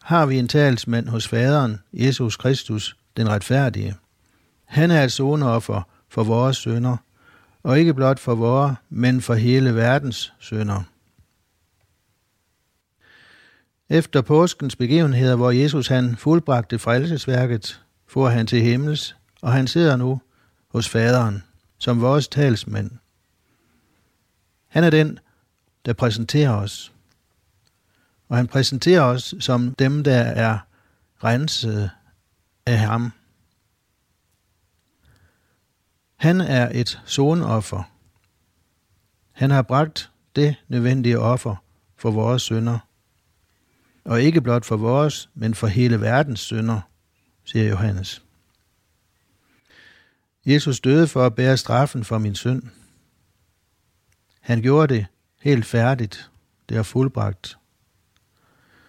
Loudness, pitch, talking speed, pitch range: -20 LUFS, 115 Hz, 110 wpm, 100-130 Hz